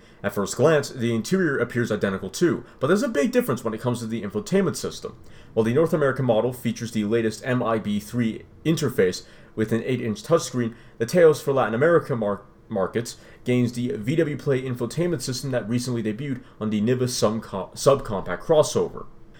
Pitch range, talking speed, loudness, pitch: 110-135 Hz, 175 wpm, -24 LUFS, 120 Hz